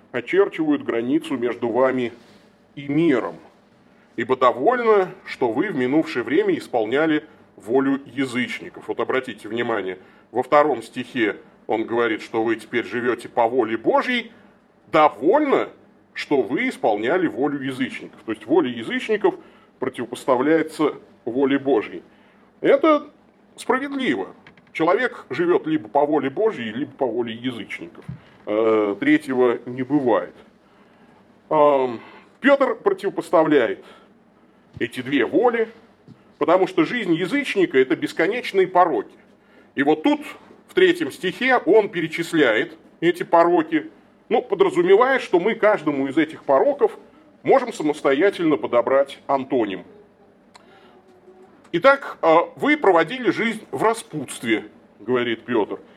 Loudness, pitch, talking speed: -21 LUFS, 210 Hz, 110 wpm